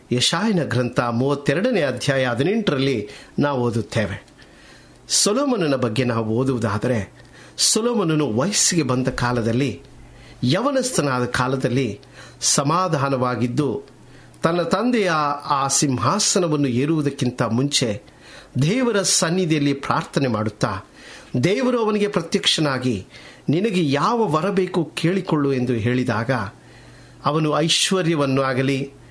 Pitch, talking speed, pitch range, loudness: 140 Hz, 80 wpm, 125-170 Hz, -20 LUFS